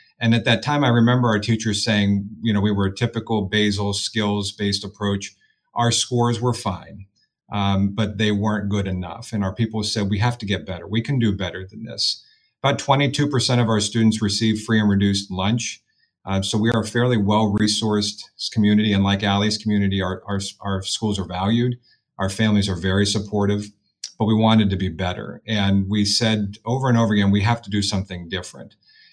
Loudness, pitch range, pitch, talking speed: -21 LUFS, 100-115 Hz, 105 Hz, 200 wpm